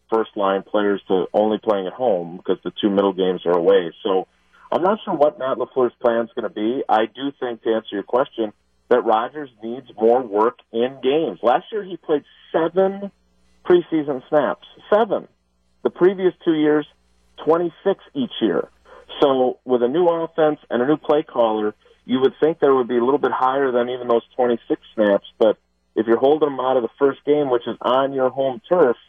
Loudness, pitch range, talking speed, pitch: -20 LUFS, 110-155 Hz, 200 wpm, 130 Hz